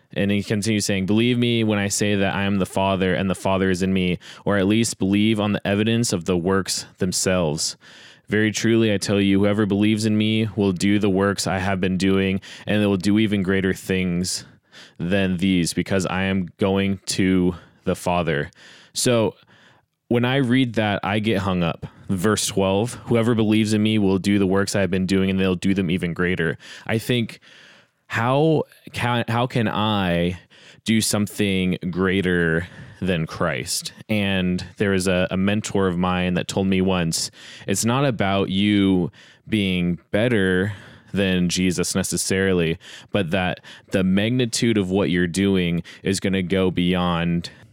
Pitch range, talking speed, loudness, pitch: 95-105 Hz, 175 wpm, -21 LUFS, 95 Hz